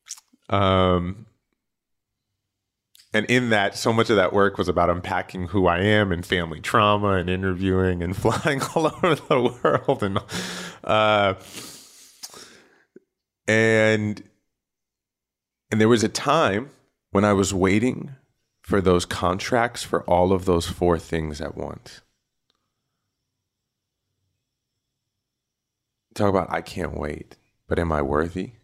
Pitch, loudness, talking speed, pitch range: 100 Hz, -22 LUFS, 120 wpm, 90-110 Hz